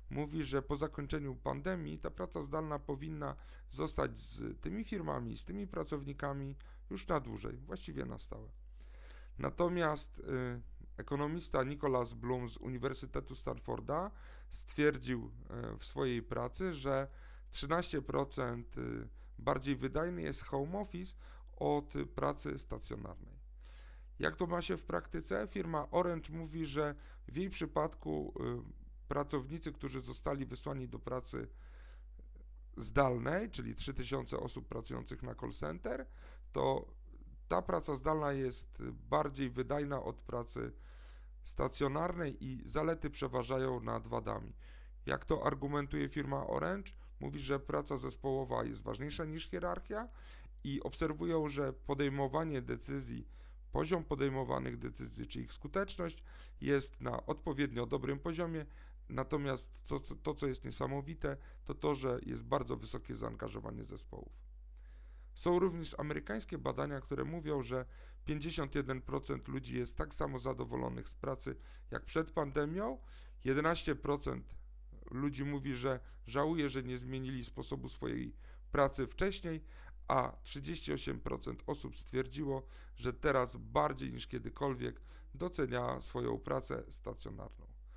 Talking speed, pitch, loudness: 120 wpm, 135 Hz, -40 LUFS